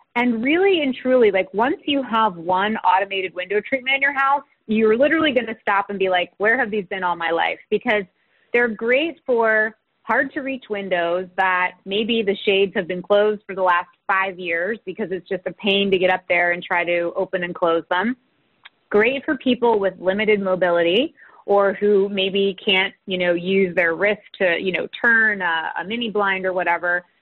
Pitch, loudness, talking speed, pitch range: 200 Hz, -20 LUFS, 200 wpm, 185-230 Hz